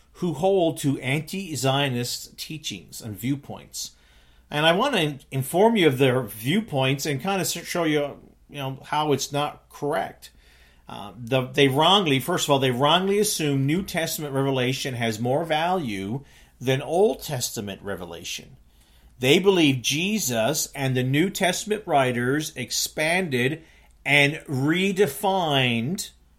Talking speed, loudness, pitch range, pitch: 130 wpm, -23 LUFS, 125-160 Hz, 140 Hz